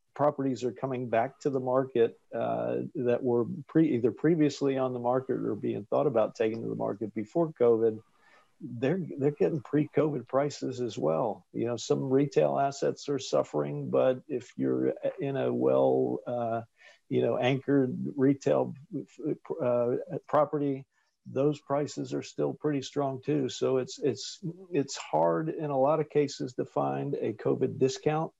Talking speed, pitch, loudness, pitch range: 160 wpm, 130 Hz, -29 LUFS, 120-145 Hz